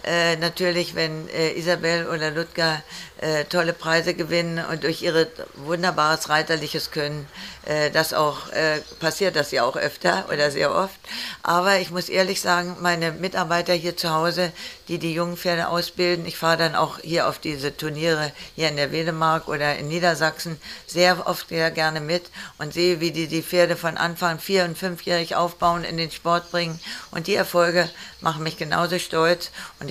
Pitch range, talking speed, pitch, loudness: 160-175 Hz, 175 wpm, 170 Hz, -23 LUFS